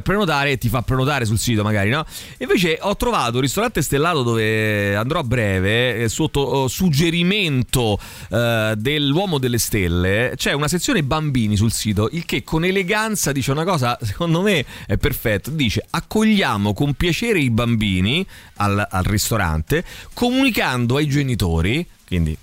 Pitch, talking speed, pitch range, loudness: 125 Hz, 145 wpm, 105-160 Hz, -19 LUFS